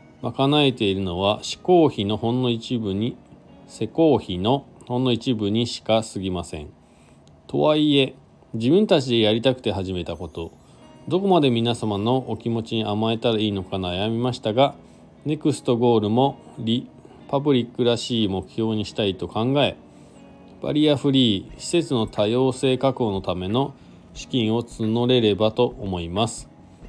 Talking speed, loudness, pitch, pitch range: 300 characters per minute, -22 LUFS, 115 Hz, 105-130 Hz